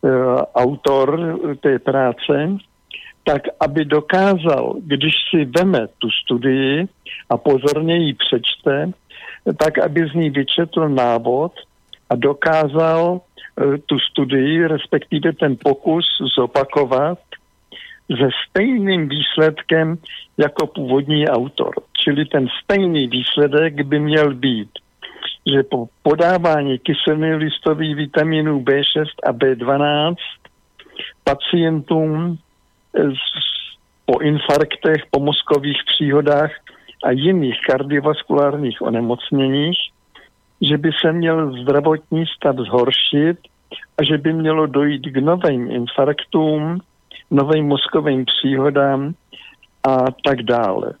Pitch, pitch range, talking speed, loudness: 150 Hz, 140-160 Hz, 100 wpm, -17 LUFS